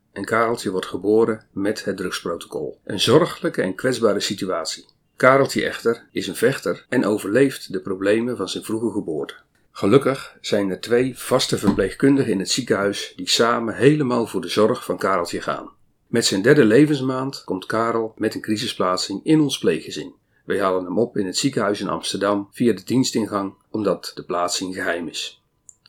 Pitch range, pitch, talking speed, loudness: 100-120 Hz, 110 Hz, 165 wpm, -21 LUFS